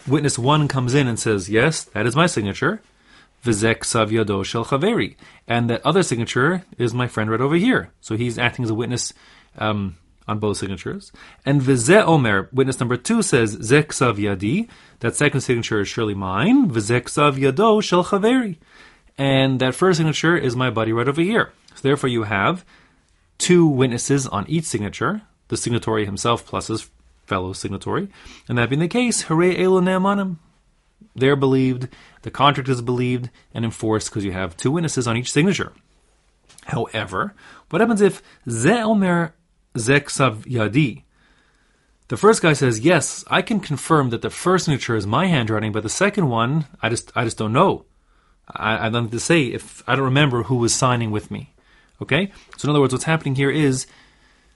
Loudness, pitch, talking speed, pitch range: -20 LUFS, 130 Hz, 170 wpm, 115-160 Hz